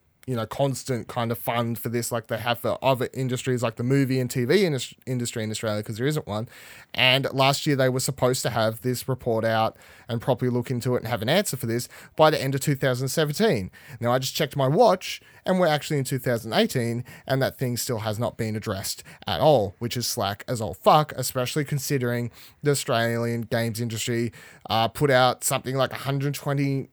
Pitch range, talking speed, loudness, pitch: 115-135 Hz, 205 wpm, -25 LUFS, 125 Hz